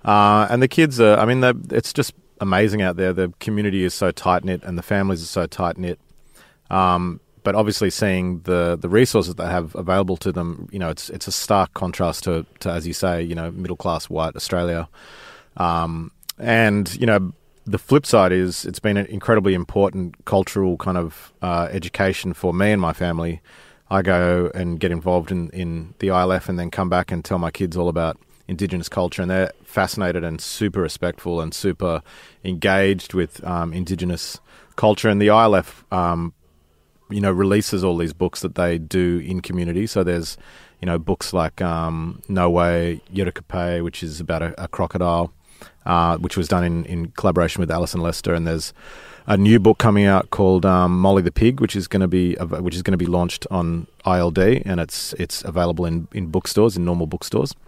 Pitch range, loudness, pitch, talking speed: 85-95 Hz, -20 LUFS, 90 Hz, 200 wpm